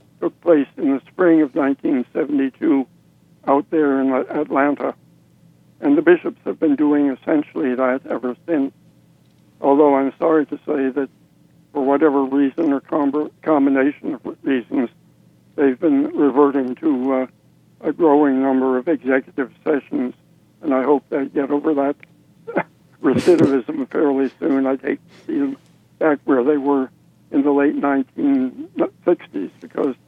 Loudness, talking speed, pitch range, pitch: -19 LUFS, 135 wpm, 135-170 Hz, 145 Hz